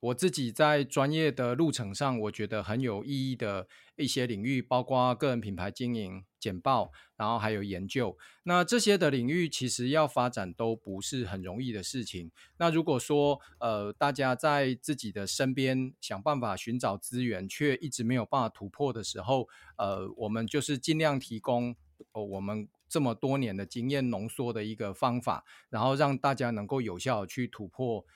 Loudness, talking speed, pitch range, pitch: -31 LUFS, 270 characters per minute, 110-140 Hz, 125 Hz